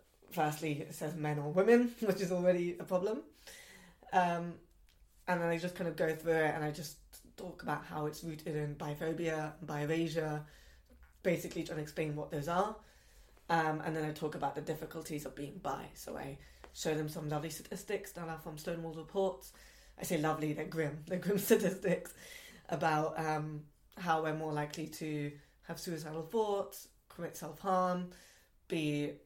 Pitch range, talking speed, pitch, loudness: 155-180 Hz, 170 wpm, 160 Hz, -37 LUFS